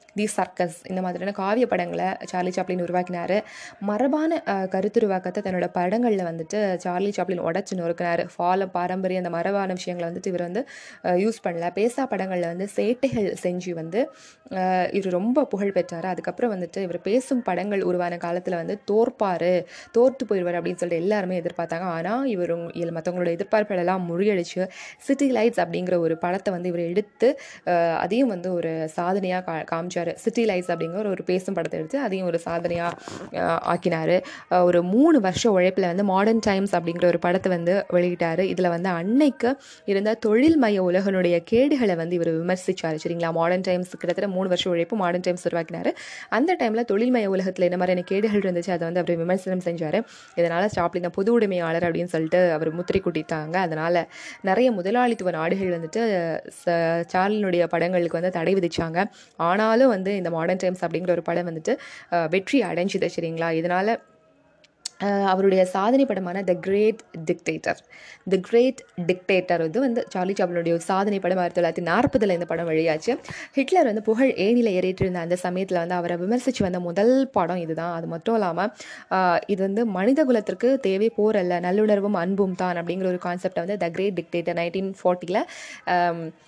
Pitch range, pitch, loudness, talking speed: 175-210 Hz, 185 Hz, -24 LUFS, 145 wpm